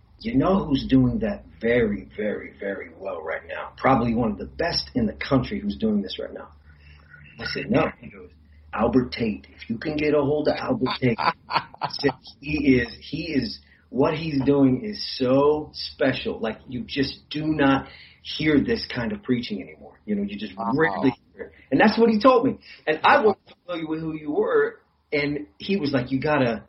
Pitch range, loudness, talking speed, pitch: 130-205 Hz, -24 LUFS, 200 wpm, 150 Hz